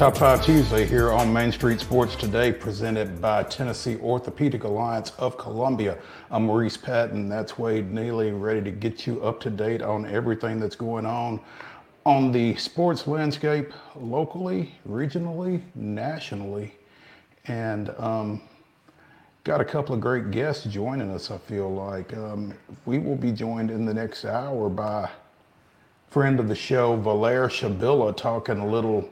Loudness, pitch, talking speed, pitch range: -25 LUFS, 115 Hz, 150 wpm, 105-130 Hz